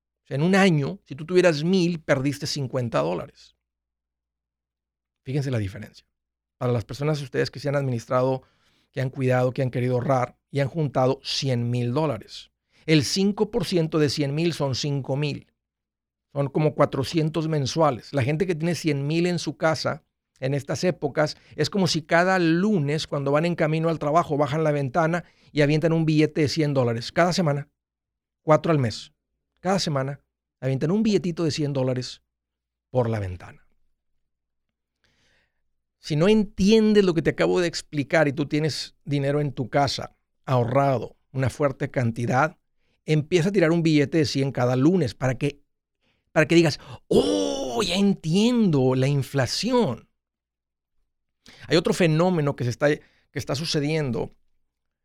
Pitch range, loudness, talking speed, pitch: 125-160 Hz, -23 LUFS, 155 wpm, 145 Hz